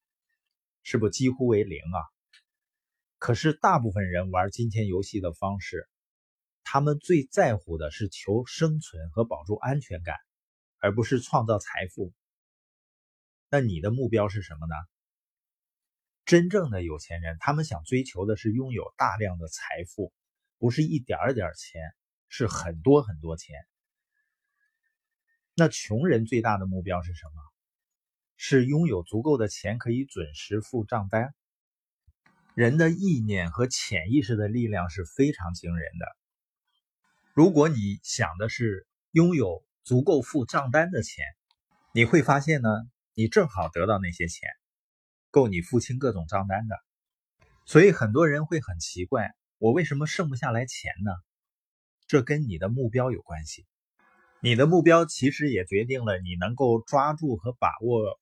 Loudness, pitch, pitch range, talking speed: -26 LUFS, 115 Hz, 95-150 Hz, 215 characters per minute